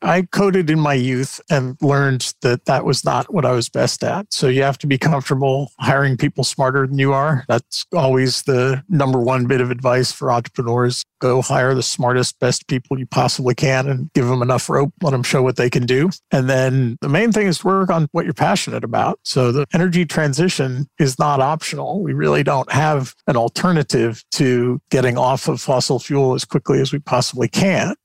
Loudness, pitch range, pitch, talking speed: -17 LUFS, 130-150 Hz, 135 Hz, 210 wpm